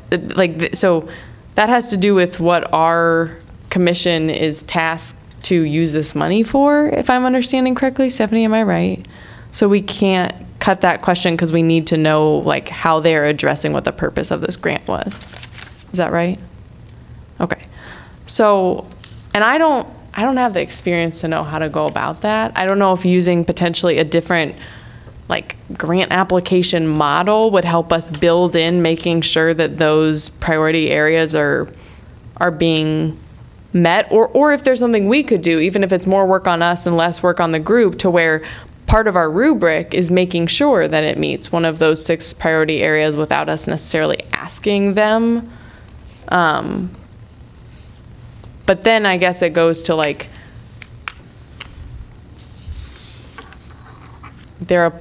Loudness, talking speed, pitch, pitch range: -15 LUFS, 165 wpm, 170 Hz, 155-195 Hz